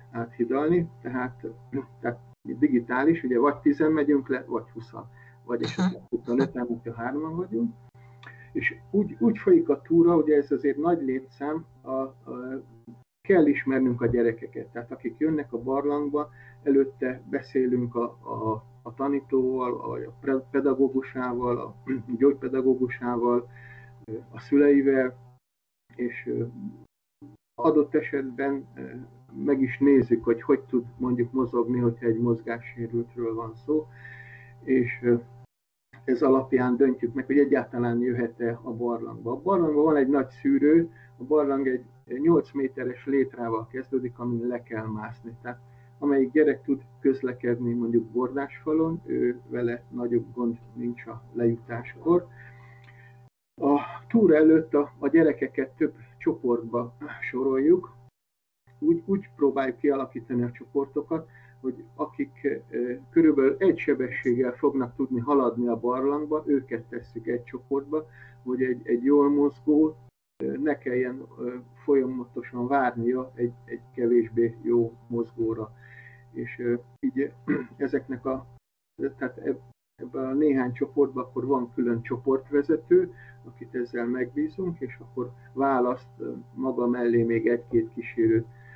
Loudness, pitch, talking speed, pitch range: -26 LUFS, 130 Hz, 125 wpm, 120-140 Hz